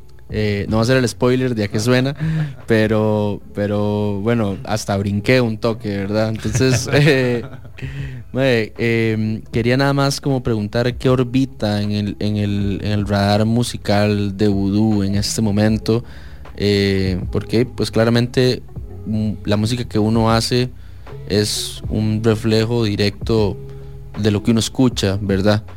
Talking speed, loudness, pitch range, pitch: 140 wpm, -18 LUFS, 105-125 Hz, 110 Hz